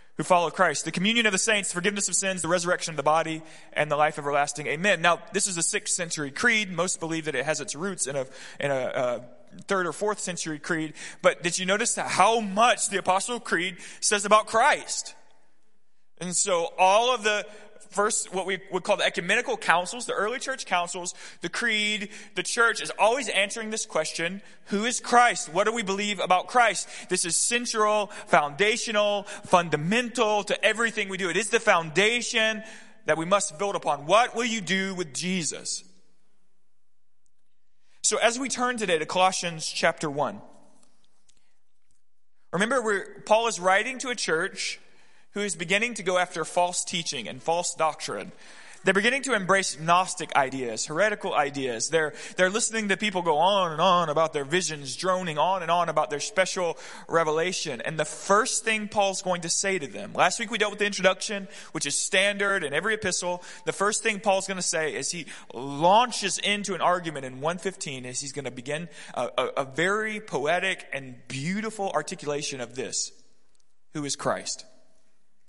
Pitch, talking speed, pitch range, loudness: 190 Hz, 180 wpm, 165-210 Hz, -25 LUFS